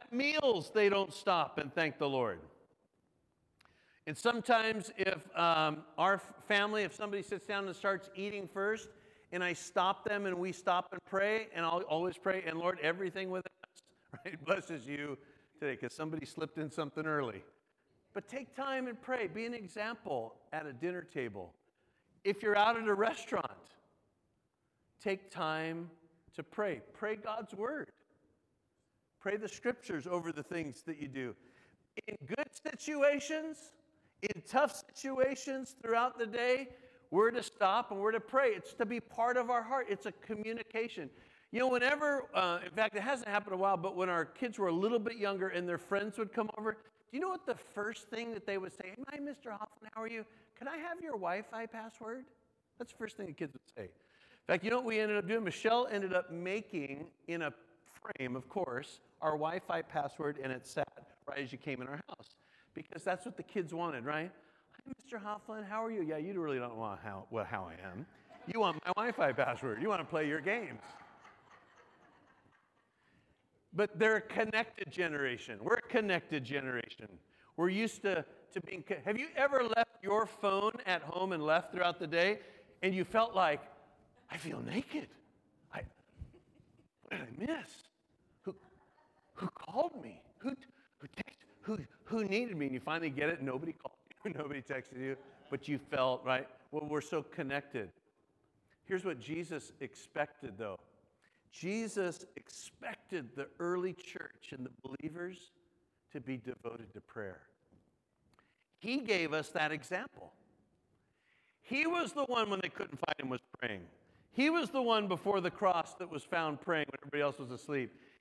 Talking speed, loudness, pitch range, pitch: 180 wpm, -37 LUFS, 155-225 Hz, 190 Hz